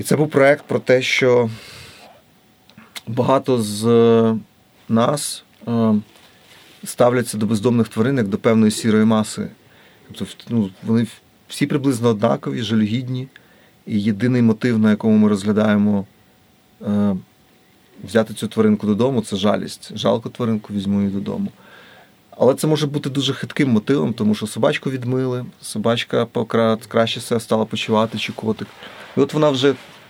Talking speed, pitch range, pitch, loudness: 135 wpm, 110-125 Hz, 115 Hz, -19 LUFS